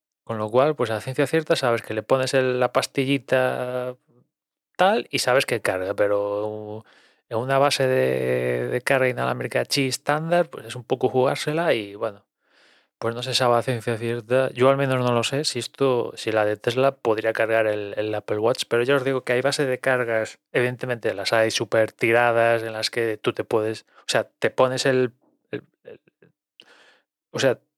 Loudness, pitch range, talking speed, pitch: -23 LUFS, 110-130 Hz, 195 wpm, 120 Hz